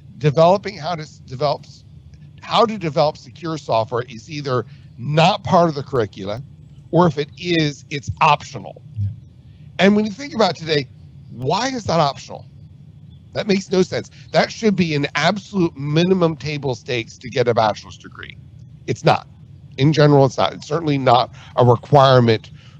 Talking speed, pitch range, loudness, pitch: 160 wpm, 130-165 Hz, -18 LUFS, 145 Hz